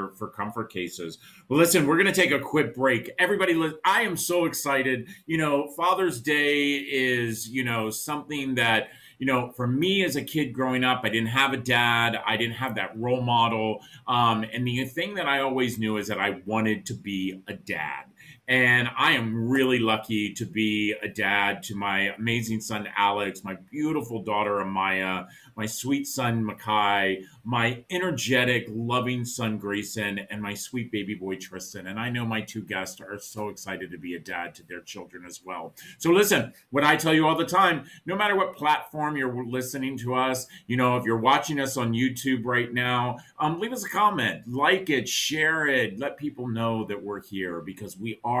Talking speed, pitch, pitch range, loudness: 195 wpm, 120 Hz, 105-140 Hz, -25 LUFS